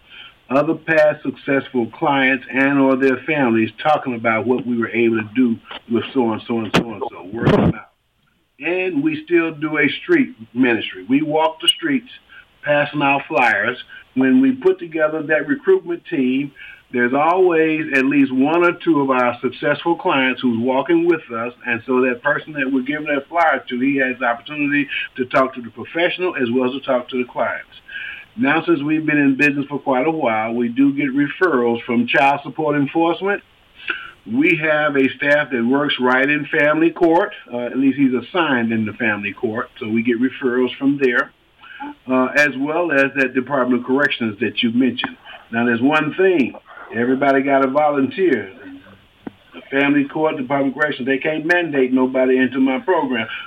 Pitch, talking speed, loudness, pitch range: 140 Hz, 185 wpm, -18 LUFS, 125-165 Hz